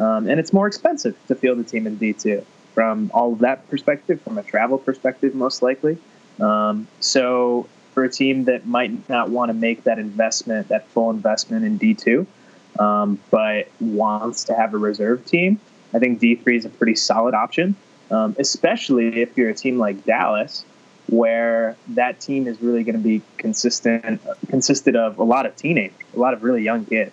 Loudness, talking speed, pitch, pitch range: -20 LUFS, 190 wpm, 120 Hz, 115-140 Hz